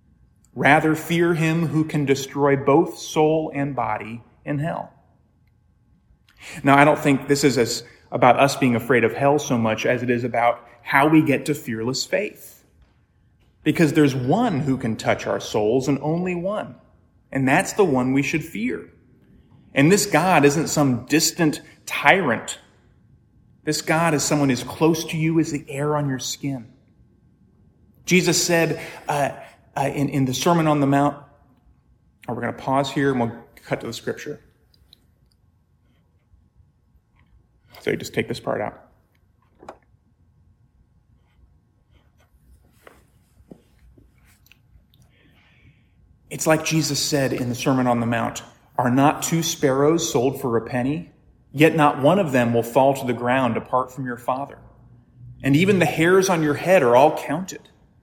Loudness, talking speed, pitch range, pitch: -20 LUFS, 155 wpm, 120-150 Hz, 135 Hz